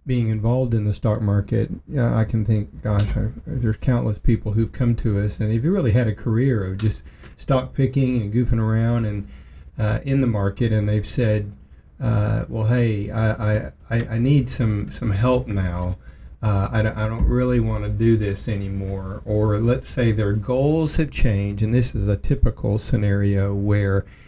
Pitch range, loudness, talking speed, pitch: 100-120 Hz, -21 LUFS, 195 wpm, 110 Hz